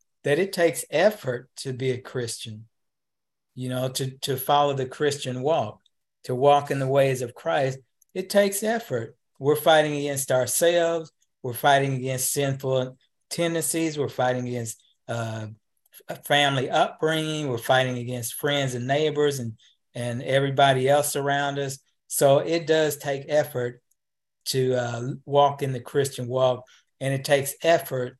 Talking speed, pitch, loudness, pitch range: 150 wpm, 135 Hz, -24 LUFS, 125-145 Hz